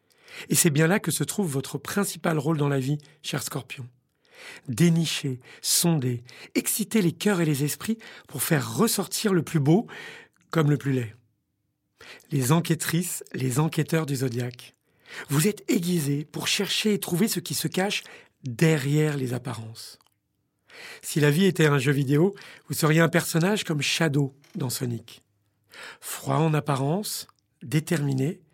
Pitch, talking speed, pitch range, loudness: 155 Hz, 150 wpm, 140-175 Hz, -25 LUFS